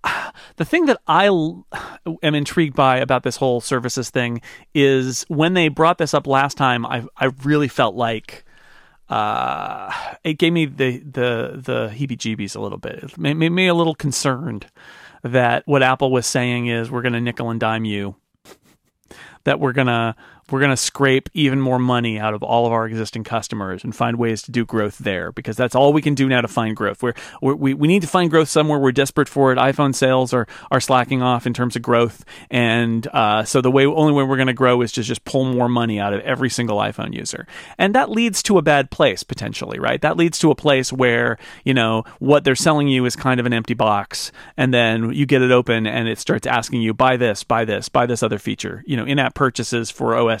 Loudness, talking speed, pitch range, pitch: -18 LUFS, 225 wpm, 115-140 Hz, 130 Hz